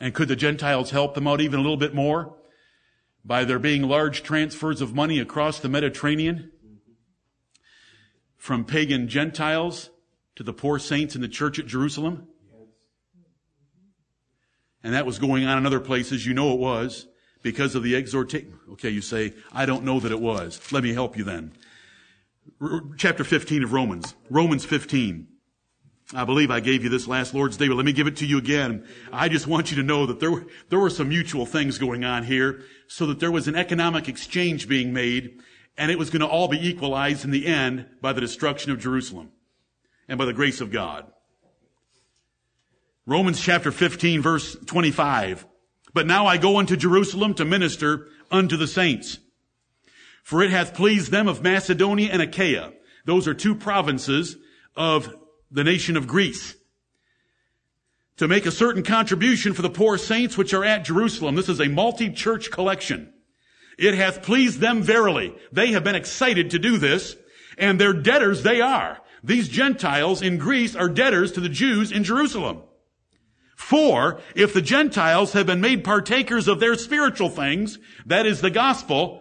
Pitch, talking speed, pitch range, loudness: 155 Hz, 175 wpm, 135-190 Hz, -22 LUFS